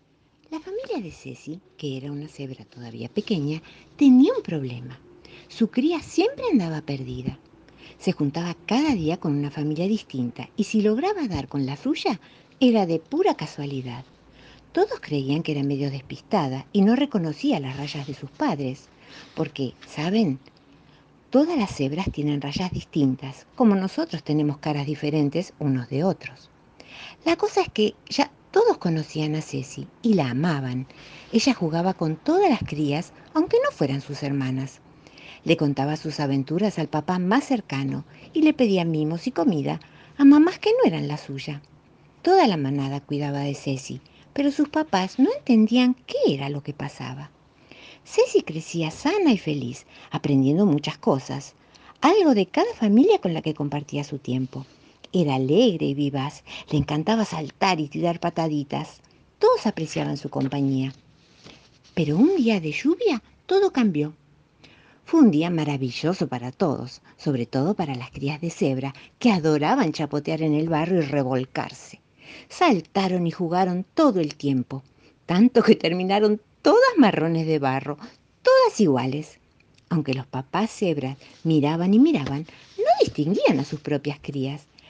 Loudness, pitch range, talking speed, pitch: -23 LUFS, 140-215 Hz, 150 wpm, 155 Hz